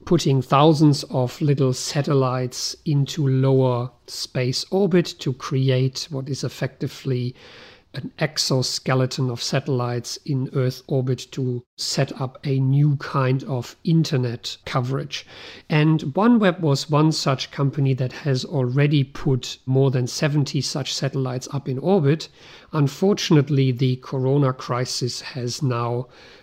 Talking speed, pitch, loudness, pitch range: 125 wpm, 135 Hz, -22 LUFS, 130-145 Hz